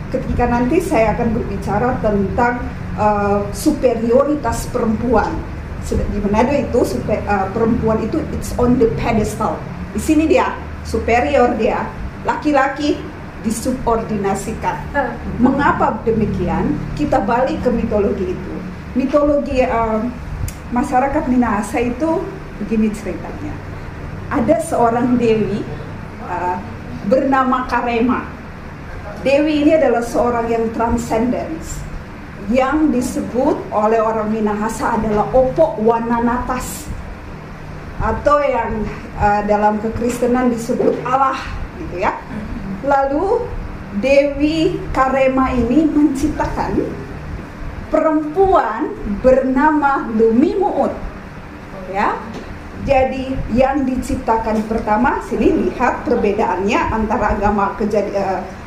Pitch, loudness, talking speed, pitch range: 240 Hz, -17 LUFS, 90 wpm, 215-275 Hz